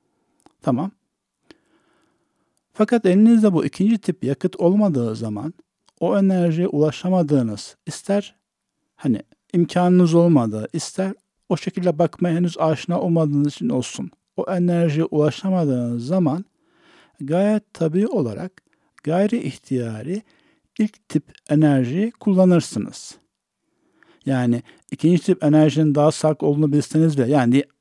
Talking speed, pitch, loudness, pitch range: 105 wpm, 170 Hz, -20 LUFS, 150-195 Hz